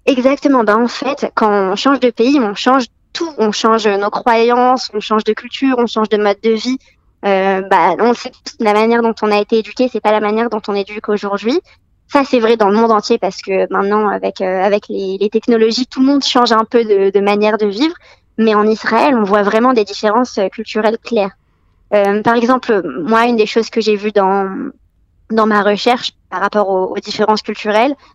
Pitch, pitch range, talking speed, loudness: 220 Hz, 205-240 Hz, 215 wpm, -14 LUFS